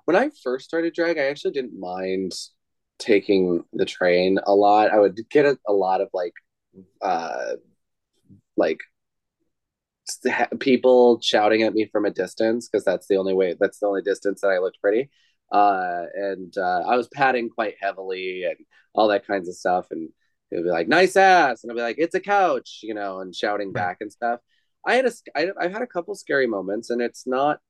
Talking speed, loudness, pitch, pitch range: 200 wpm, -22 LUFS, 110 Hz, 95-145 Hz